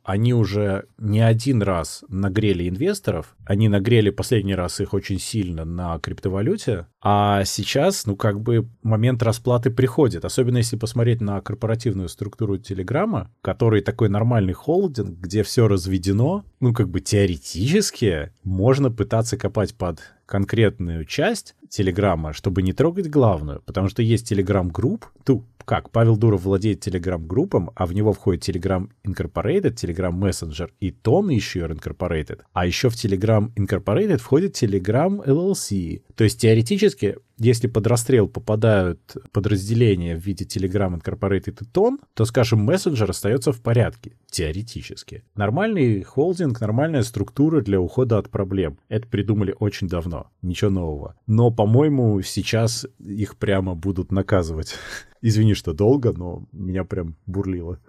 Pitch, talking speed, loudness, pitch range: 105 Hz, 140 wpm, -21 LUFS, 95-120 Hz